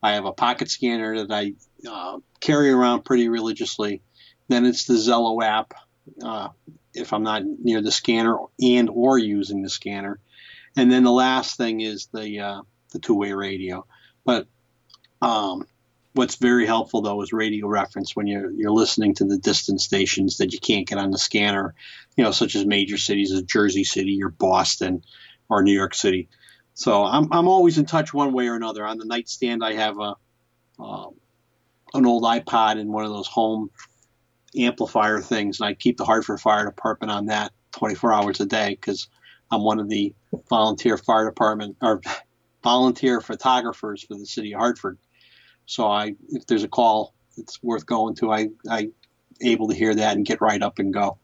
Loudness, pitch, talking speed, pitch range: -22 LUFS, 110 Hz, 185 wpm, 100-120 Hz